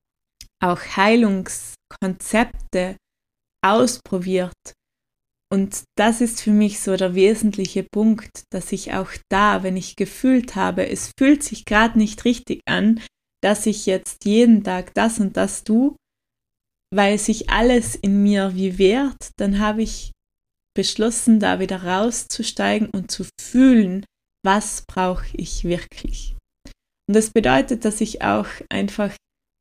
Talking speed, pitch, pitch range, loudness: 130 wpm, 205 Hz, 190-225 Hz, -19 LUFS